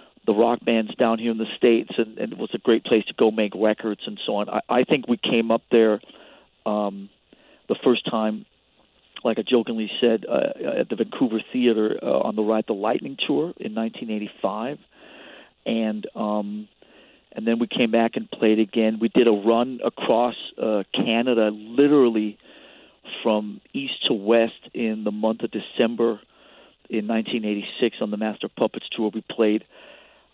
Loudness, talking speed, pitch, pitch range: -23 LUFS, 170 wpm, 110 Hz, 110-115 Hz